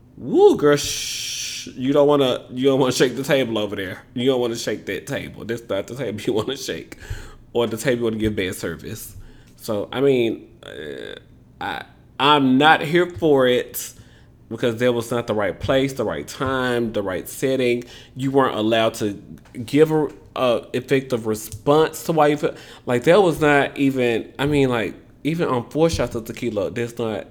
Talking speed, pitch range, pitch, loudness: 195 wpm, 115-140 Hz, 125 Hz, -20 LUFS